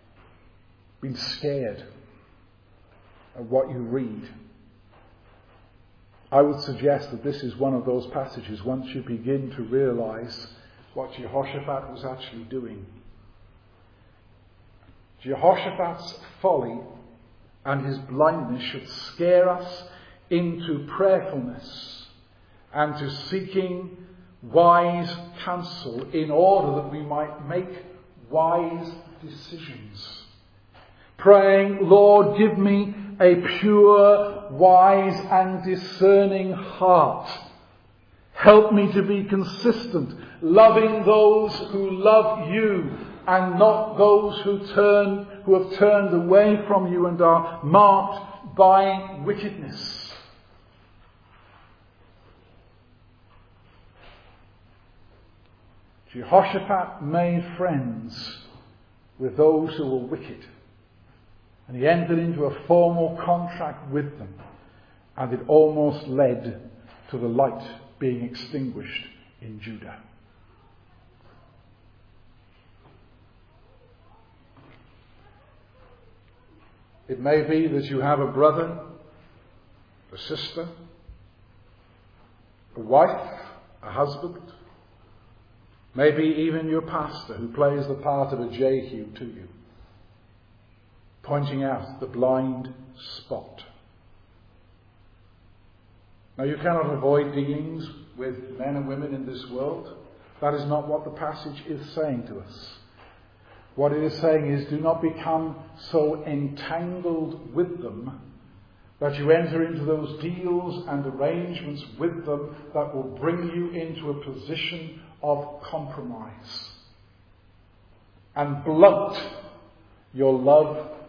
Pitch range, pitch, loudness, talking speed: 105-165 Hz, 135 Hz, -22 LUFS, 100 wpm